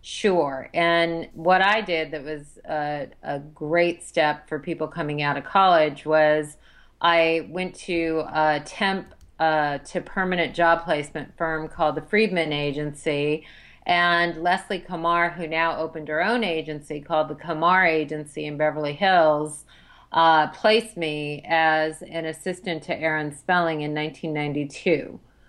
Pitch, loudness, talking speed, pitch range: 160 Hz, -23 LUFS, 140 wpm, 150-170 Hz